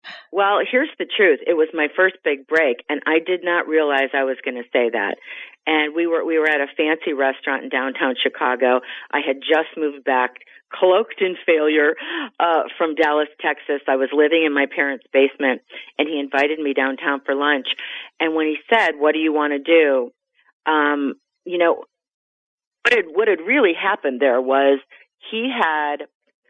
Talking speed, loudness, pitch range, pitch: 190 wpm, -19 LUFS, 140-170 Hz, 150 Hz